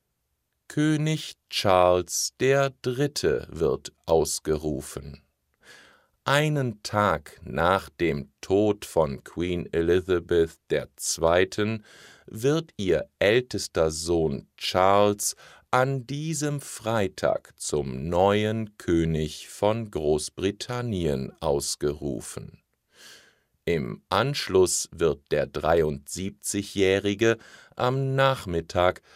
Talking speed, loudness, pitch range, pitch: 70 wpm, -26 LUFS, 80-125 Hz, 100 Hz